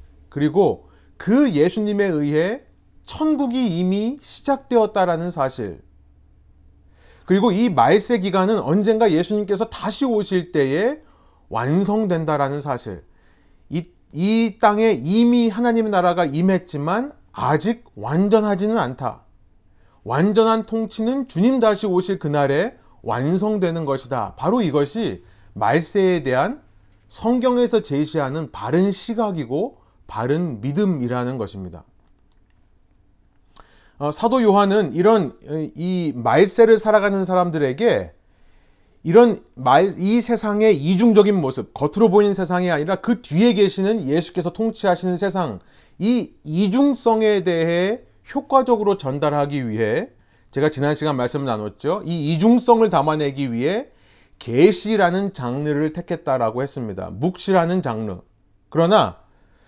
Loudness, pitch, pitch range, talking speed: -19 LUFS, 175 Hz, 135-215 Hz, 265 characters per minute